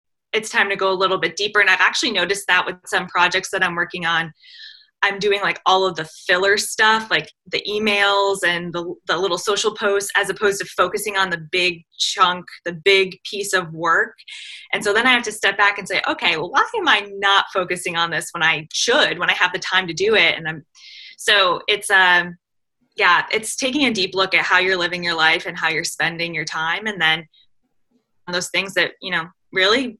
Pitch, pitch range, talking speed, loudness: 190 Hz, 175-205 Hz, 225 wpm, -18 LUFS